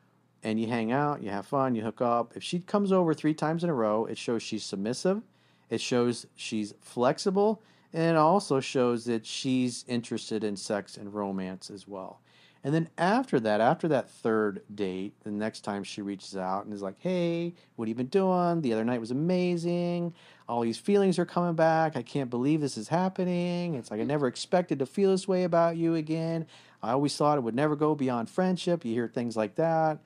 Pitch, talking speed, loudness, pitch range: 135 Hz, 210 wpm, -29 LUFS, 110-170 Hz